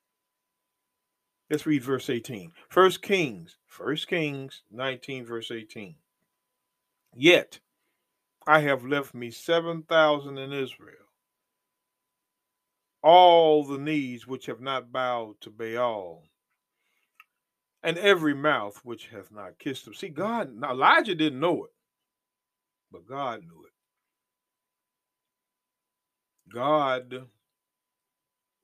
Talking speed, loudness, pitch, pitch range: 105 wpm, -25 LUFS, 140 Hz, 125-160 Hz